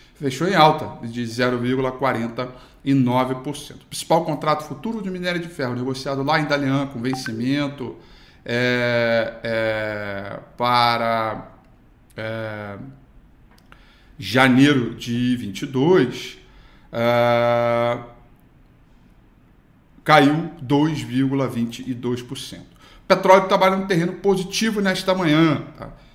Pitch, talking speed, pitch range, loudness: 130 Hz, 85 wpm, 120-150 Hz, -20 LUFS